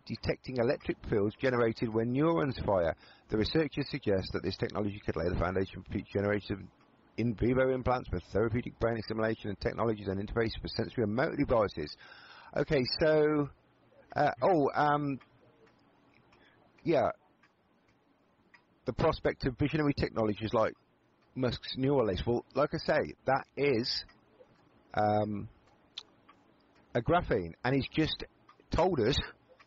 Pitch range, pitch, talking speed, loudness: 105-135 Hz, 115 Hz, 130 wpm, -32 LUFS